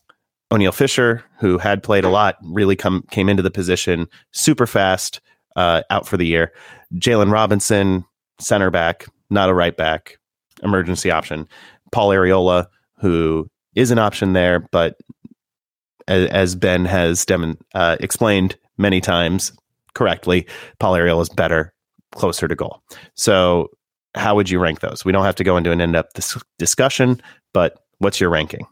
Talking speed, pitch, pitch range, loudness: 155 wpm, 95 Hz, 85-100 Hz, -17 LUFS